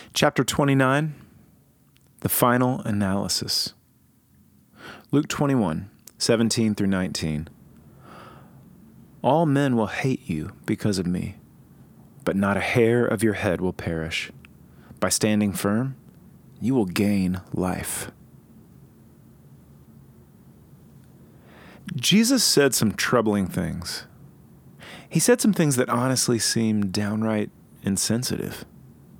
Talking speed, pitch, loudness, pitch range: 105 wpm, 110 Hz, -23 LUFS, 100-130 Hz